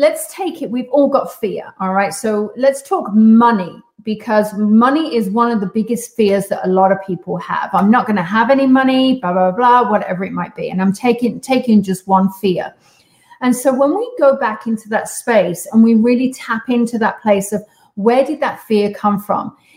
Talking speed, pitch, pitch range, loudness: 215 wpm, 225 Hz, 200-255 Hz, -15 LUFS